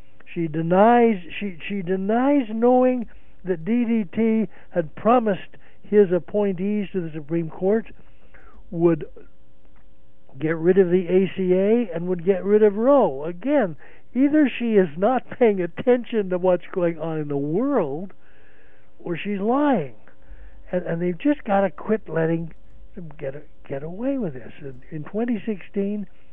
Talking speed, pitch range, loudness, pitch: 140 wpm, 160-220 Hz, -22 LUFS, 185 Hz